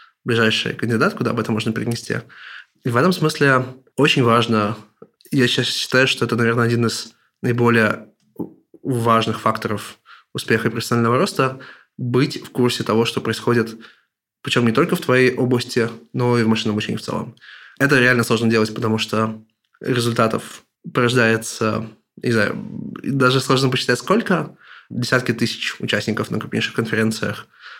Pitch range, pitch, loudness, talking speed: 115-130 Hz, 120 Hz, -19 LUFS, 145 wpm